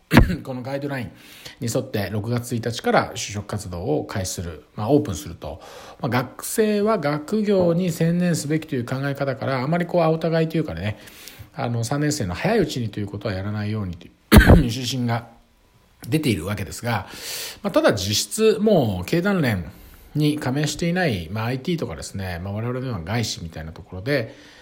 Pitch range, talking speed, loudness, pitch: 100-150 Hz, 375 characters per minute, -22 LUFS, 120 Hz